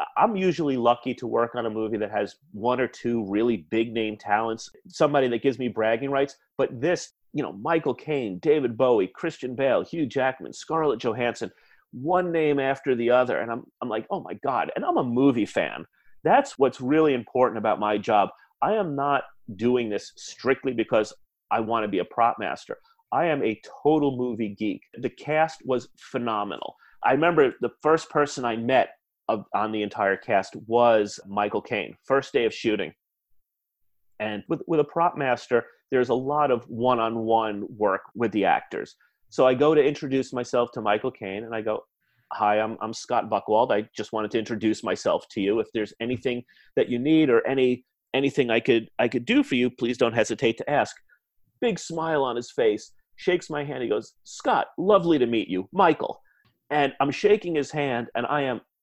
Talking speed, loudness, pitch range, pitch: 195 wpm, -25 LUFS, 115-145 Hz, 125 Hz